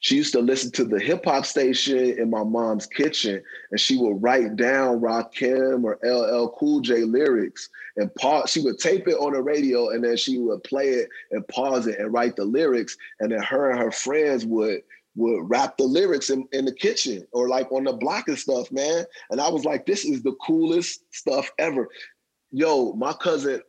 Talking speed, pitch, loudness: 210 wpm, 130 Hz, -23 LUFS